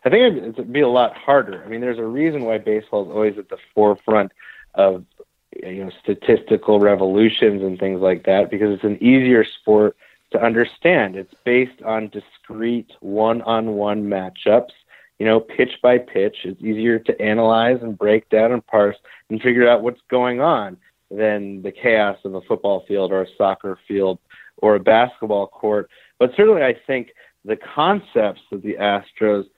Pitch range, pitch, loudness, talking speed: 100-120 Hz, 105 Hz, -18 LUFS, 175 wpm